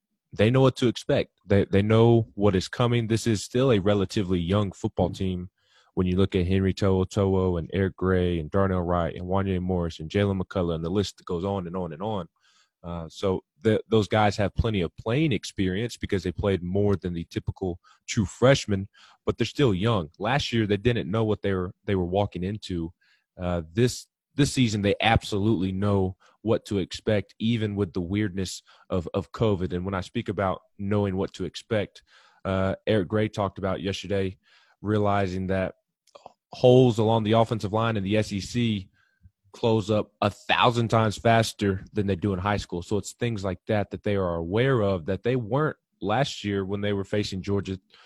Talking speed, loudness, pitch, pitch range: 195 wpm, -26 LUFS, 100 Hz, 95-110 Hz